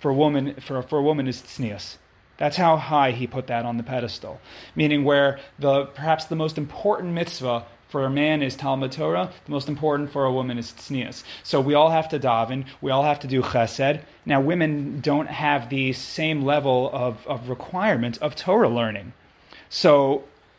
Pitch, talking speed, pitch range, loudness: 140 Hz, 195 wpm, 125-150 Hz, -23 LUFS